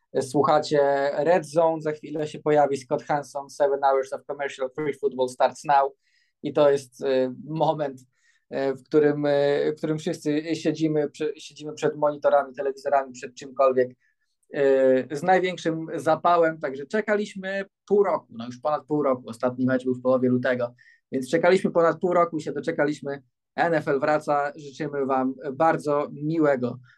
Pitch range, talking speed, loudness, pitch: 135-160 Hz, 145 wpm, -24 LUFS, 145 Hz